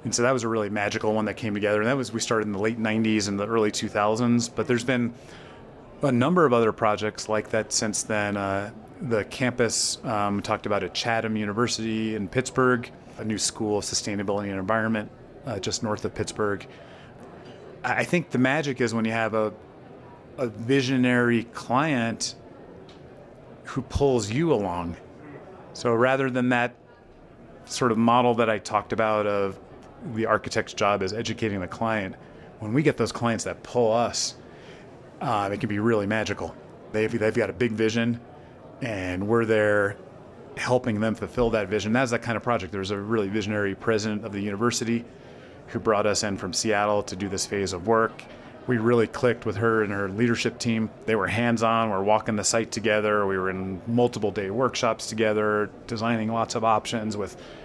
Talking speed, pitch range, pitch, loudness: 185 wpm, 105-120 Hz, 110 Hz, -25 LUFS